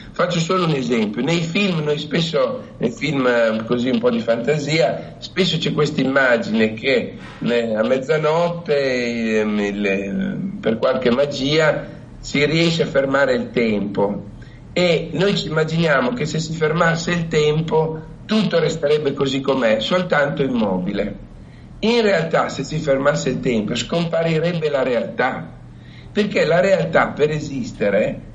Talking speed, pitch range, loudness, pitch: 130 wpm, 130-170 Hz, -19 LUFS, 150 Hz